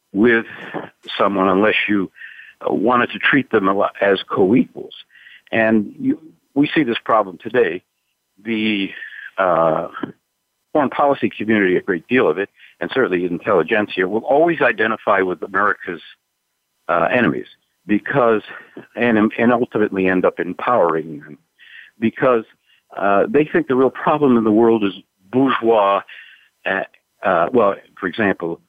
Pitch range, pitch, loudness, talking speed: 100-120 Hz, 110 Hz, -18 LUFS, 130 wpm